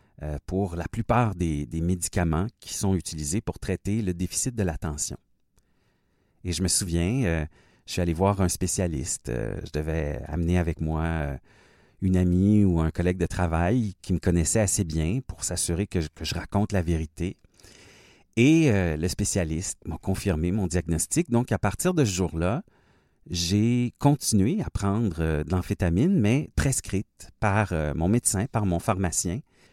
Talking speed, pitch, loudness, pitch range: 155 wpm, 90 Hz, -26 LUFS, 85-105 Hz